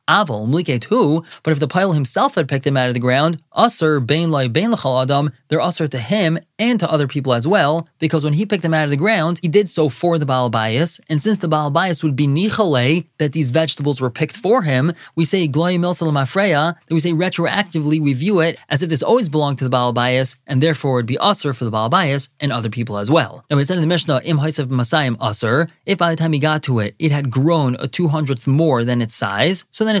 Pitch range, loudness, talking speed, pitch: 135-170 Hz, -17 LUFS, 225 wpm, 155 Hz